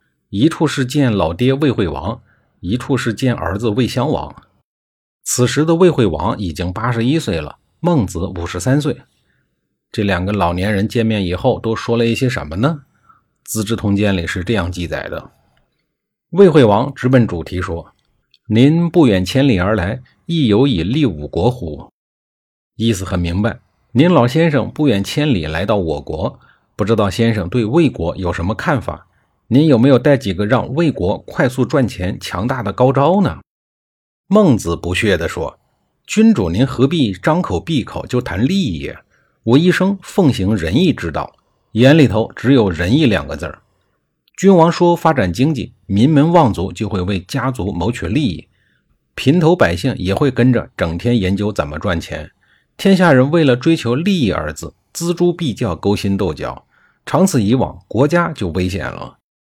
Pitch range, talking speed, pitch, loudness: 95-140 Hz, 245 characters per minute, 115 Hz, -15 LUFS